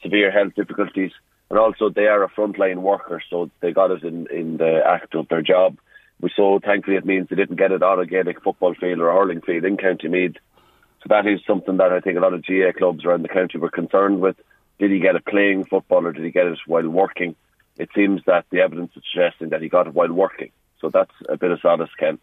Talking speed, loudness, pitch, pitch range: 255 wpm, -19 LUFS, 95 Hz, 85-100 Hz